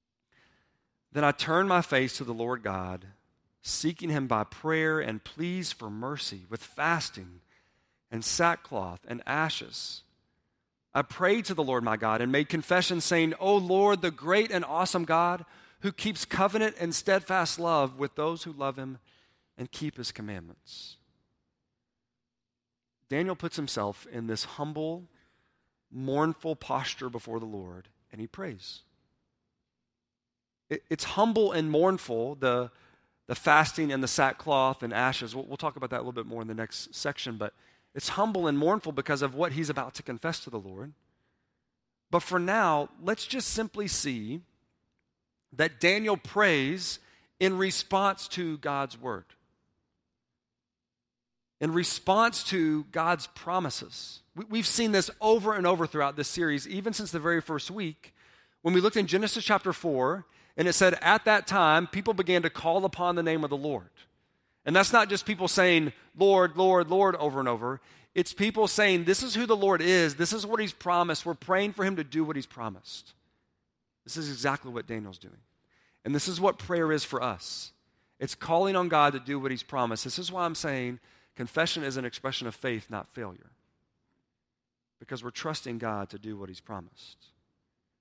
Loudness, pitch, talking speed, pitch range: -28 LUFS, 155 Hz, 170 wpm, 120-180 Hz